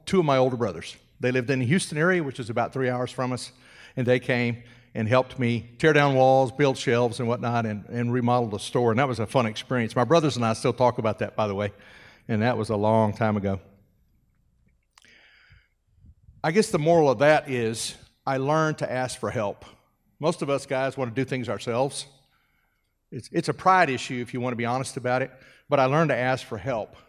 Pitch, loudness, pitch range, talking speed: 125 Hz, -24 LUFS, 115-135 Hz, 225 wpm